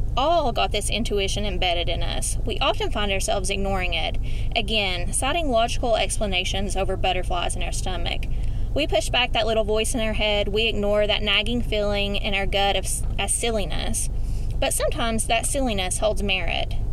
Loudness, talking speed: -23 LUFS, 170 wpm